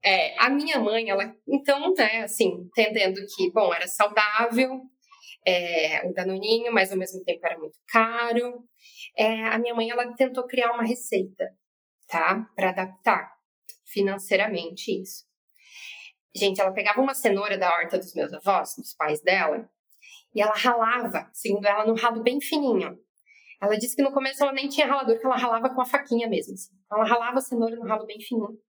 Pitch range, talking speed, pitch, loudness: 195-250 Hz, 175 wpm, 225 Hz, -24 LUFS